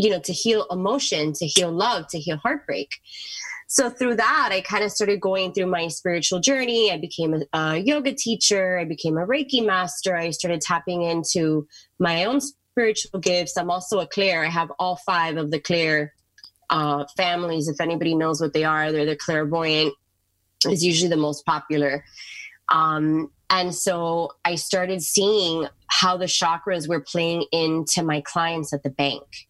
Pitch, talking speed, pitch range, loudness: 170 Hz, 175 wpm, 155-185 Hz, -22 LUFS